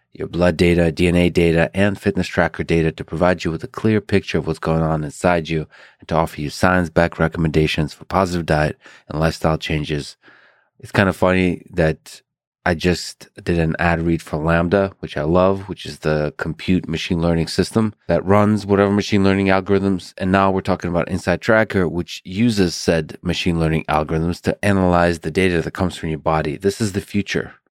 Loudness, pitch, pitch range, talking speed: -19 LUFS, 85 Hz, 80-95 Hz, 195 wpm